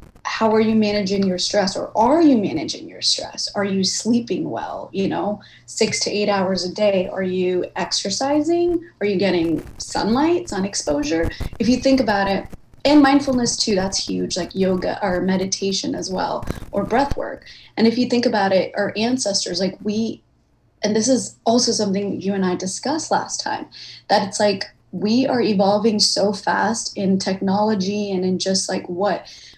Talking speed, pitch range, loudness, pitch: 180 wpm, 190-230 Hz, -20 LUFS, 205 Hz